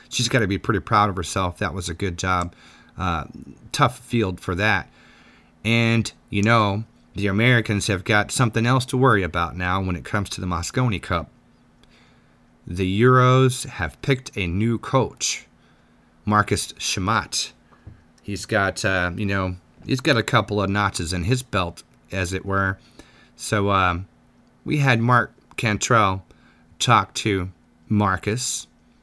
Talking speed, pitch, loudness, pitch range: 150 wpm, 100 Hz, -22 LUFS, 90-115 Hz